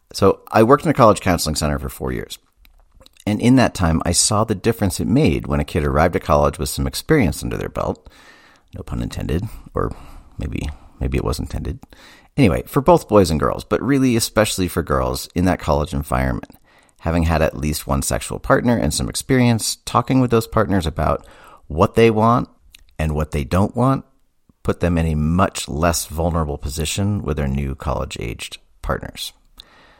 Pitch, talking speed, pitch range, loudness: 80 Hz, 185 wpm, 70-105 Hz, -19 LUFS